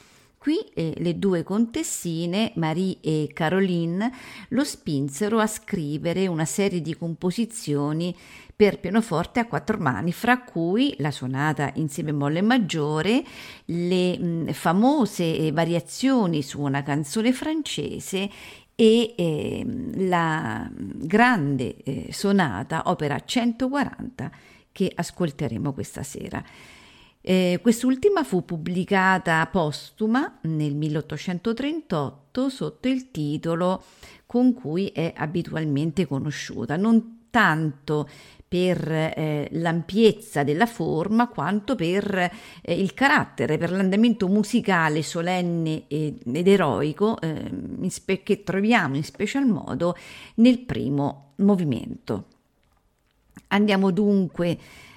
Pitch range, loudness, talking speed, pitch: 155-220 Hz, -24 LUFS, 105 wpm, 180 Hz